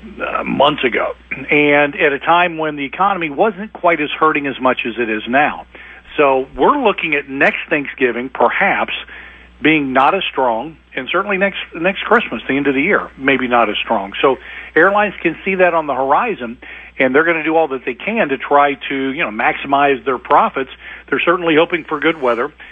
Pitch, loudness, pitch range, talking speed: 145 Hz, -15 LUFS, 135-170 Hz, 200 wpm